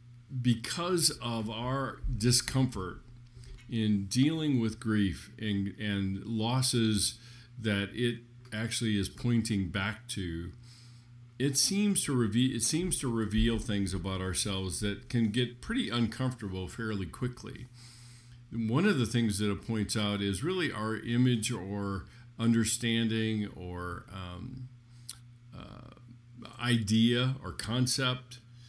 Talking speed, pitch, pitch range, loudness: 120 wpm, 120 Hz, 105-125 Hz, -31 LUFS